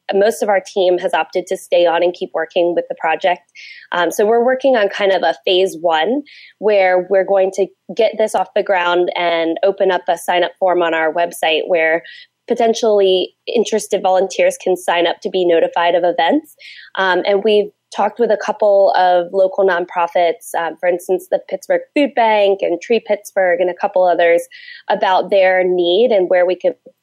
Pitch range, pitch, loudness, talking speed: 175-210 Hz, 185 Hz, -15 LUFS, 195 wpm